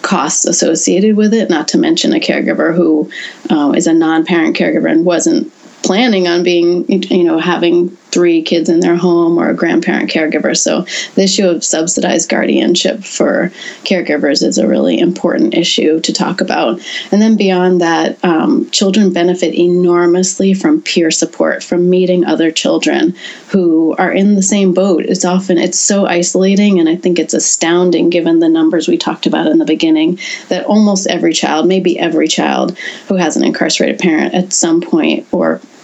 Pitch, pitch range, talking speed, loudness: 180 Hz, 170-215 Hz, 175 wpm, -11 LUFS